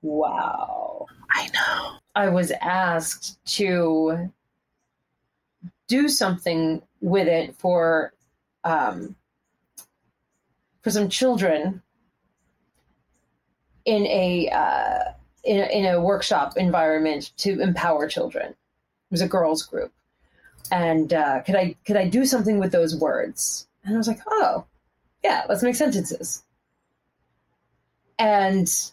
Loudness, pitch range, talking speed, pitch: -23 LUFS, 170-225 Hz, 110 wpm, 190 Hz